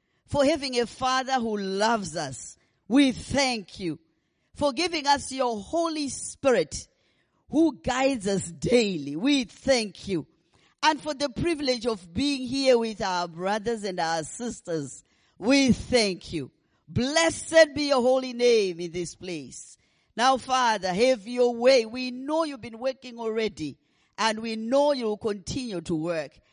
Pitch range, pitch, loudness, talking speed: 190-270 Hz, 240 Hz, -26 LUFS, 145 wpm